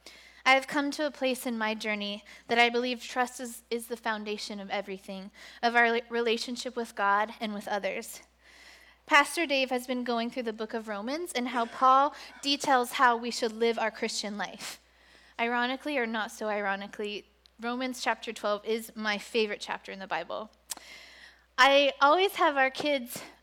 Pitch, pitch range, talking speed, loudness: 235 Hz, 215-260 Hz, 175 wpm, -29 LUFS